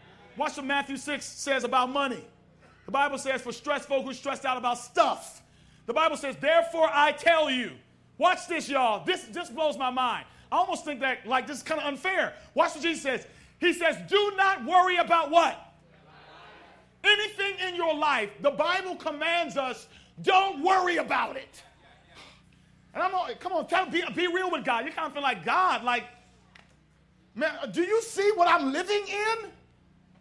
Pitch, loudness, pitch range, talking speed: 315 Hz, -27 LUFS, 270-355 Hz, 185 wpm